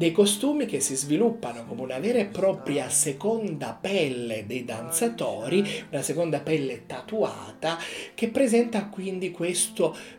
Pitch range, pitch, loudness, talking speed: 150-230 Hz, 190 Hz, -26 LUFS, 130 wpm